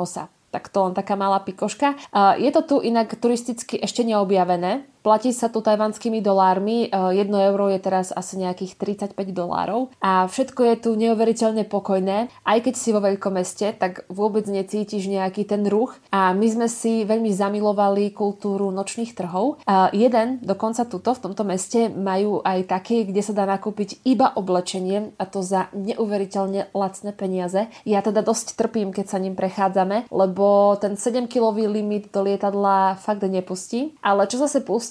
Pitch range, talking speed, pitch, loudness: 195-225 Hz, 165 wpm, 205 Hz, -22 LUFS